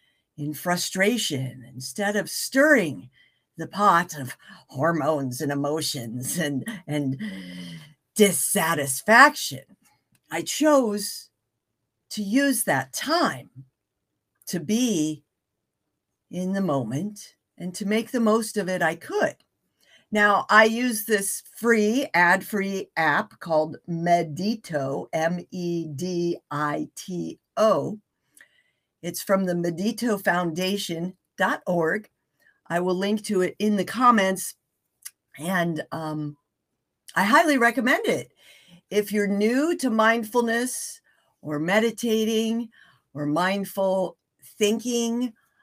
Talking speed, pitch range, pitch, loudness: 105 wpm, 150-220 Hz, 185 Hz, -24 LUFS